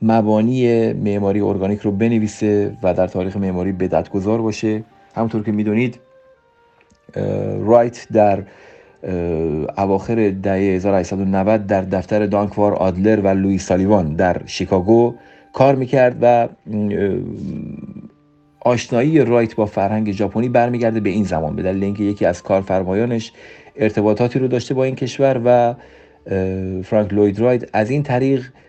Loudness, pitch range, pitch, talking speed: -17 LUFS, 95-120 Hz, 105 Hz, 125 wpm